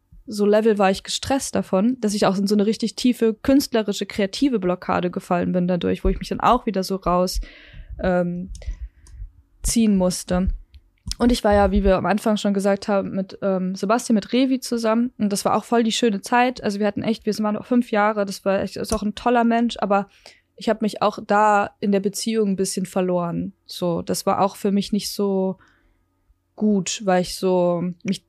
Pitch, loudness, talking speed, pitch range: 200 Hz, -21 LUFS, 210 wpm, 185-220 Hz